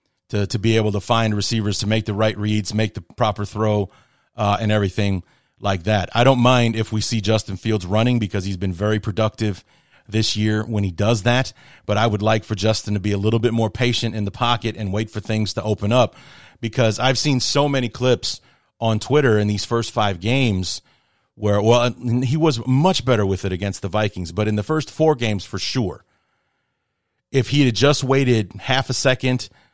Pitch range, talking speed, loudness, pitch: 105-125 Hz, 210 wpm, -20 LUFS, 110 Hz